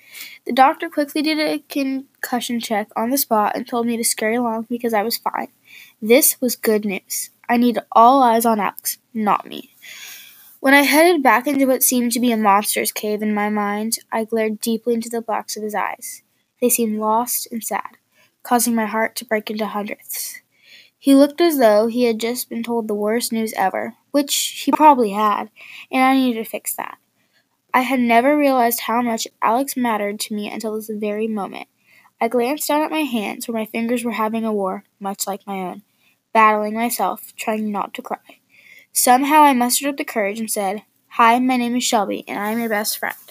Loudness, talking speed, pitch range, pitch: -18 LUFS, 200 wpm, 215-255 Hz, 230 Hz